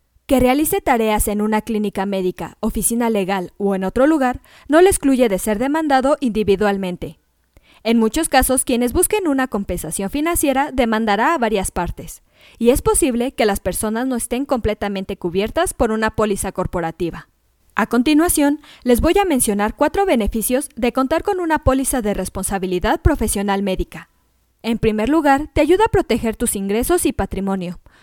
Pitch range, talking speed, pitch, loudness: 200-280 Hz, 160 wpm, 230 Hz, -18 LUFS